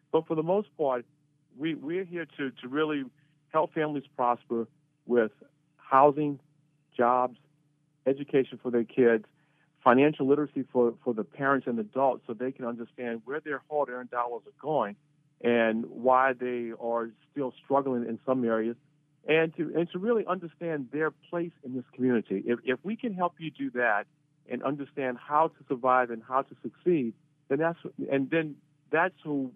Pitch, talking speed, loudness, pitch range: 140 Hz, 165 wpm, -29 LUFS, 125-155 Hz